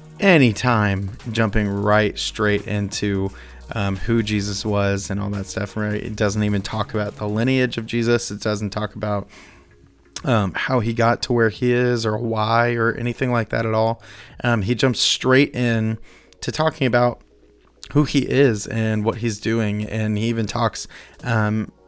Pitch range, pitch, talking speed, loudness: 105-120 Hz, 110 Hz, 175 wpm, -20 LUFS